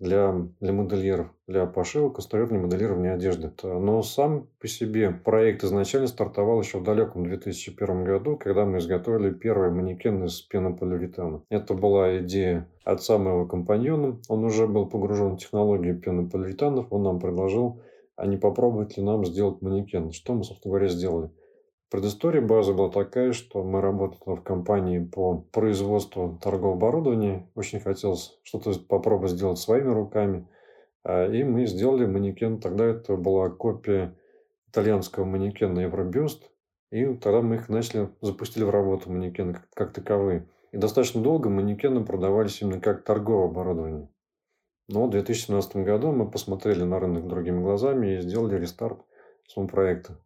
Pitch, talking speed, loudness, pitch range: 100 Hz, 145 wpm, -26 LUFS, 95-110 Hz